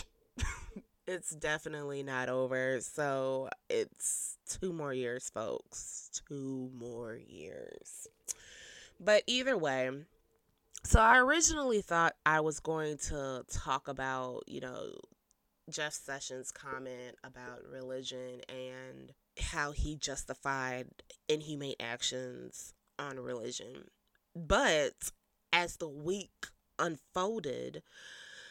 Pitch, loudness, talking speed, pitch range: 145 Hz, -35 LUFS, 95 wpm, 130-185 Hz